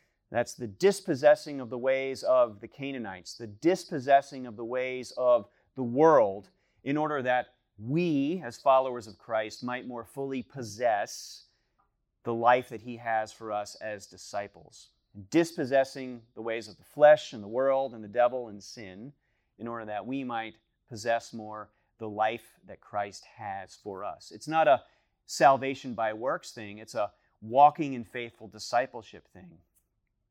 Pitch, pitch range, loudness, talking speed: 120 Hz, 110-135 Hz, -29 LUFS, 160 wpm